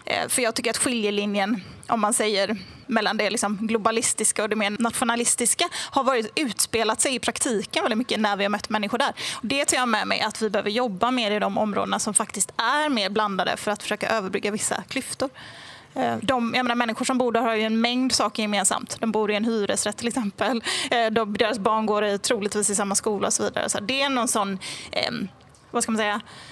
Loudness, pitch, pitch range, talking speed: -23 LUFS, 220 Hz, 210-240 Hz, 220 wpm